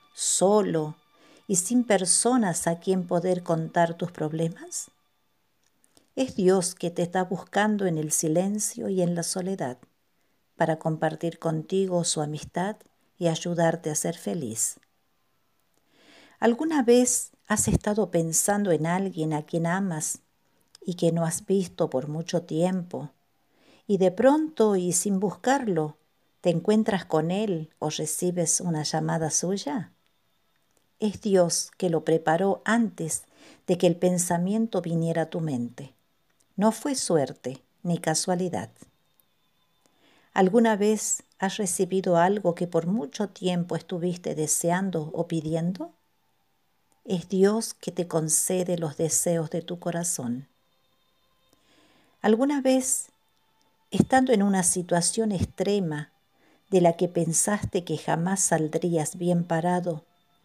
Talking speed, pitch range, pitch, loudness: 125 wpm, 165-200 Hz, 175 Hz, -25 LUFS